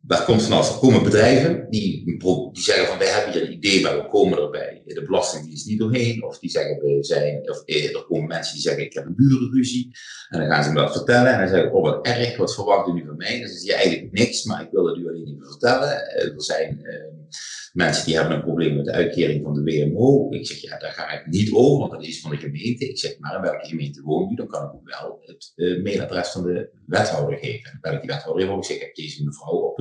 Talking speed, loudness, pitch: 280 wpm, -21 LUFS, 100 Hz